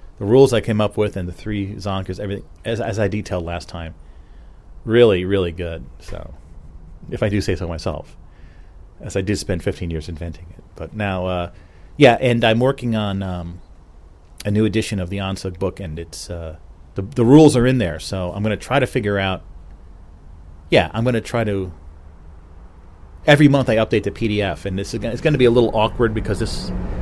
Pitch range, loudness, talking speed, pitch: 80-110 Hz, -19 LUFS, 205 wpm, 95 Hz